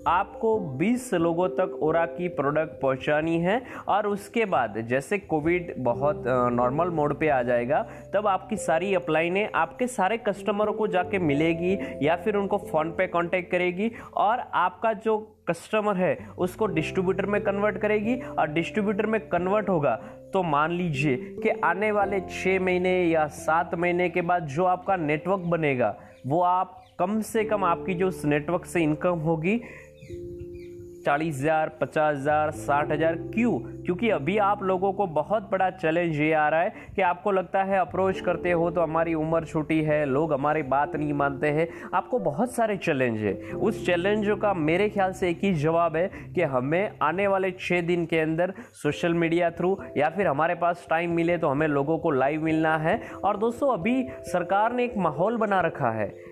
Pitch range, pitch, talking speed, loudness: 155-195 Hz, 175 Hz, 180 wpm, -25 LUFS